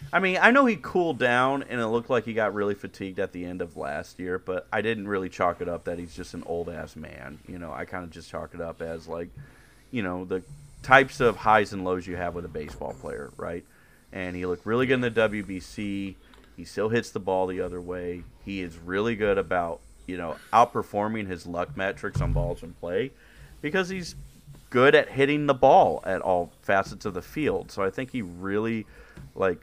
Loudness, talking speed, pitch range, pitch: -26 LUFS, 225 wpm, 90-125 Hz, 95 Hz